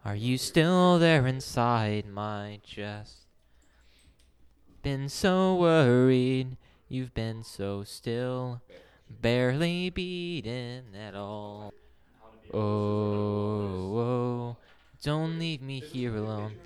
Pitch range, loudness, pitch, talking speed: 105-130 Hz, -28 LUFS, 115 Hz, 90 wpm